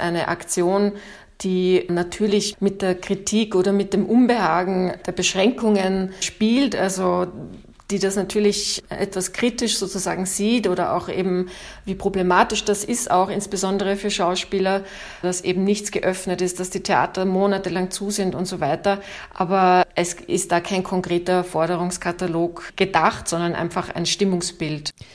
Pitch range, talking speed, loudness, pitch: 180-200 Hz, 140 wpm, -21 LUFS, 185 Hz